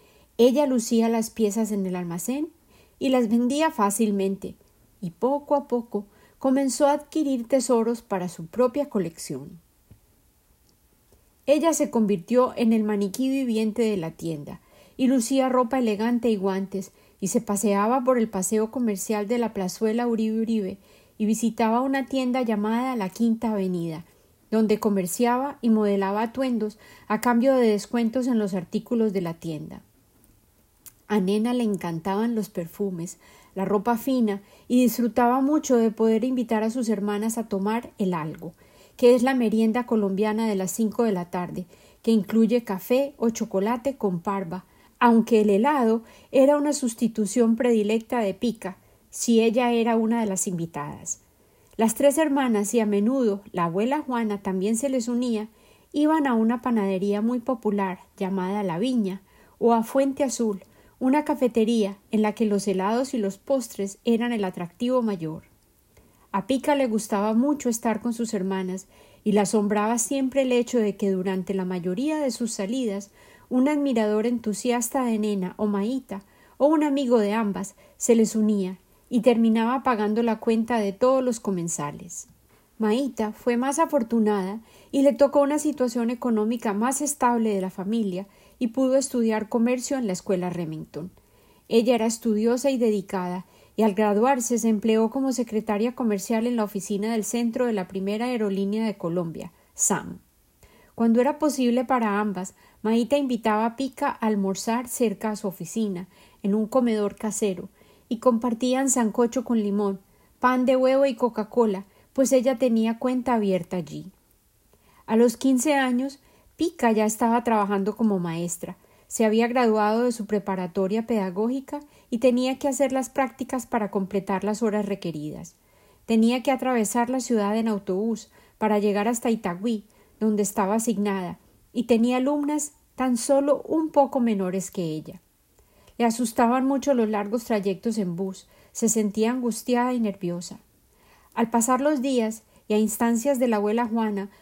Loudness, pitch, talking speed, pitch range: -24 LUFS, 225 Hz, 155 wpm, 200-250 Hz